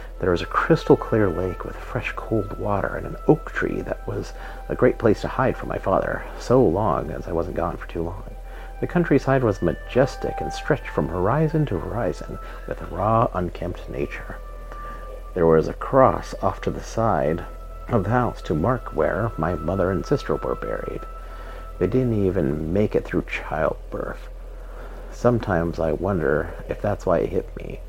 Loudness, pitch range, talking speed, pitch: -23 LUFS, 85-115 Hz, 180 wpm, 95 Hz